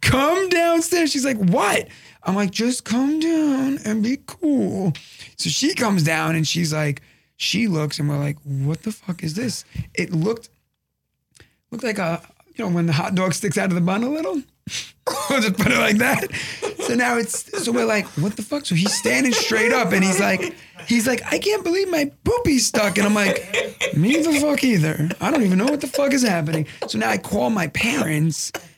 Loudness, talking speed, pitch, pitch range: -20 LUFS, 210 wpm, 215 Hz, 170-275 Hz